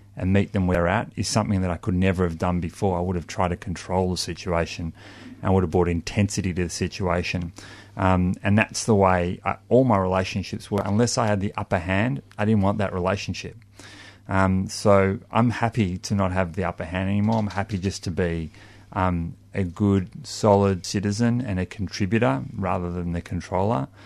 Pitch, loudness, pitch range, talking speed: 95 Hz, -24 LUFS, 90-105 Hz, 200 wpm